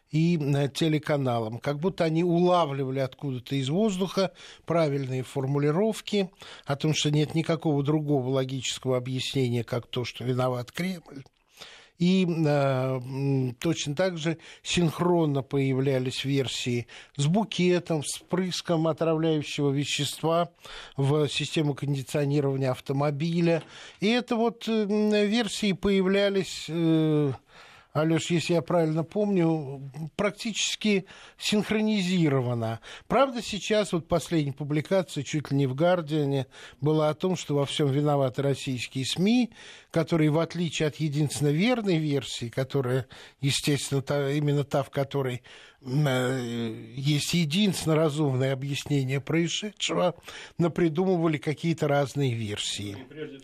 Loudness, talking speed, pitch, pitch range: -27 LUFS, 110 wpm, 150 Hz, 135-170 Hz